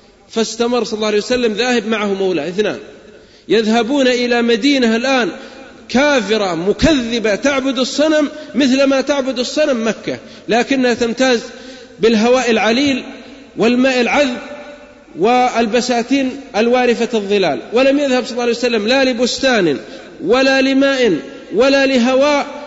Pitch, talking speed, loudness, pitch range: 250 Hz, 115 wpm, -14 LUFS, 230-270 Hz